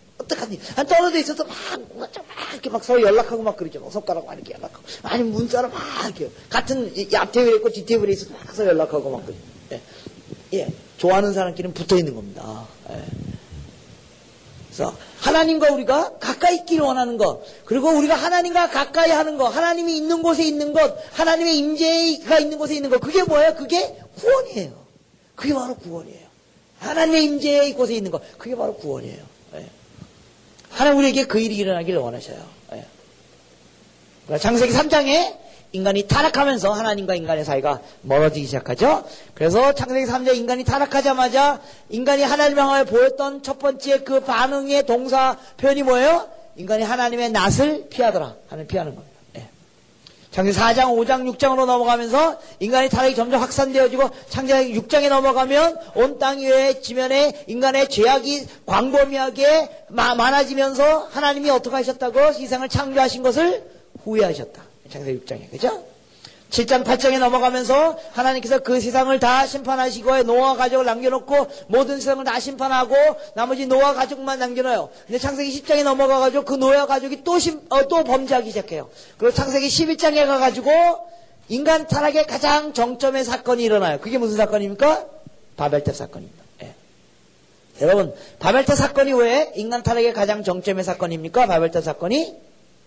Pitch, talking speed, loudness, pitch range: 265 Hz, 360 characters per minute, -19 LUFS, 235-290 Hz